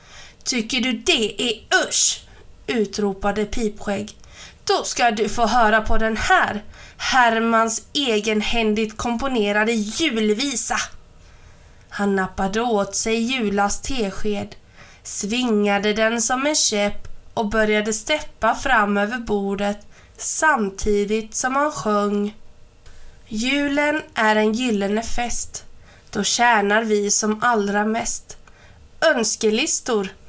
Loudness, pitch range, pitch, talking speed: -20 LUFS, 210-240 Hz, 220 Hz, 105 wpm